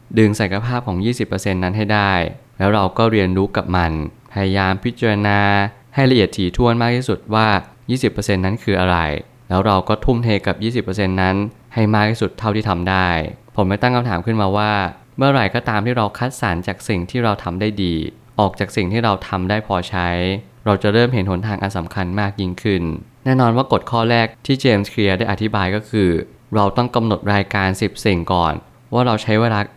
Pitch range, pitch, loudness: 95-115 Hz, 105 Hz, -18 LUFS